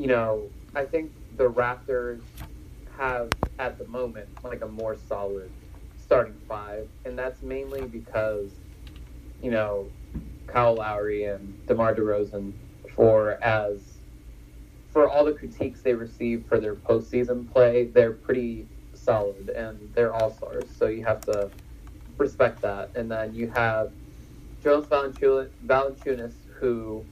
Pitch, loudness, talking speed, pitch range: 110 Hz, -26 LUFS, 130 wpm, 100-125 Hz